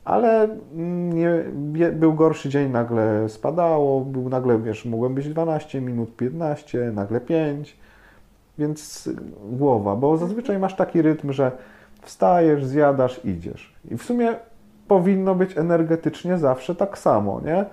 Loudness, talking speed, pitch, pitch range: -22 LUFS, 130 wpm, 150 Hz, 125-170 Hz